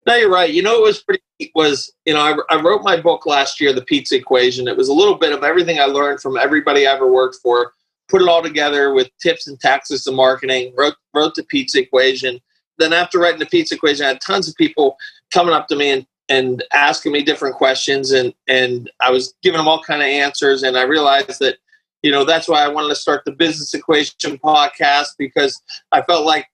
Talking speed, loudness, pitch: 235 wpm, -15 LUFS, 150 Hz